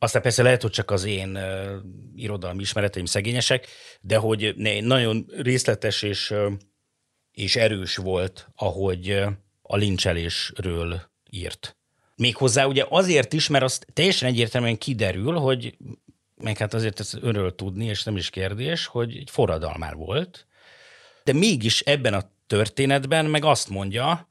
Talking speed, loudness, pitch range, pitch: 135 wpm, -23 LUFS, 100-130 Hz, 110 Hz